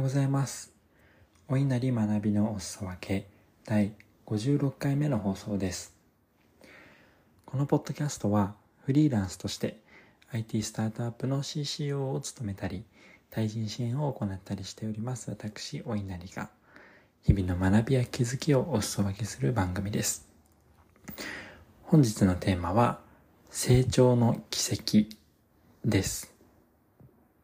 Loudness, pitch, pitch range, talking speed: -30 LUFS, 105 Hz, 100-130 Hz, 240 characters per minute